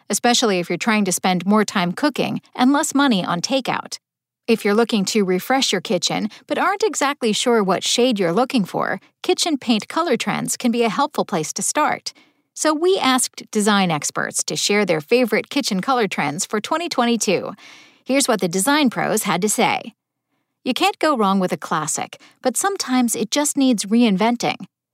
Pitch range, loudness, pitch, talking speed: 205-275 Hz, -19 LUFS, 235 Hz, 185 wpm